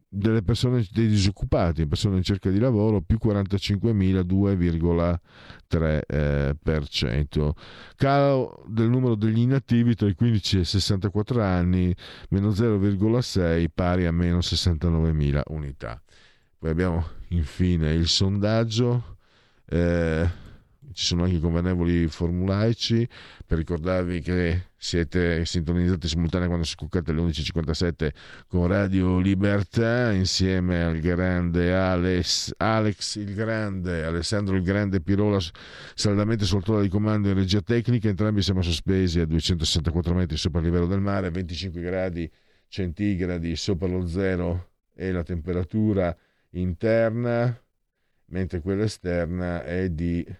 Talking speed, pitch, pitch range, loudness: 120 wpm, 90 Hz, 85-105 Hz, -24 LUFS